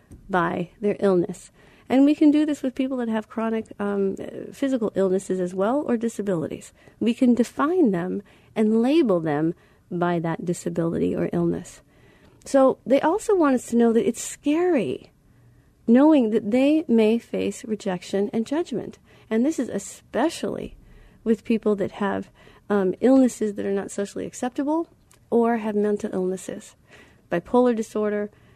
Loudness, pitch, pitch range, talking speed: -23 LUFS, 220 Hz, 190-255 Hz, 150 wpm